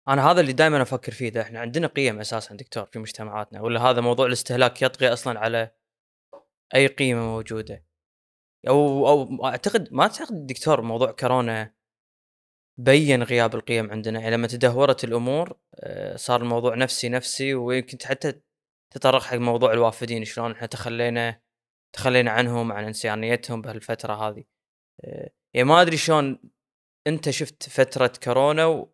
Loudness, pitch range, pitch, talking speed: -23 LUFS, 115-135 Hz, 120 Hz, 145 wpm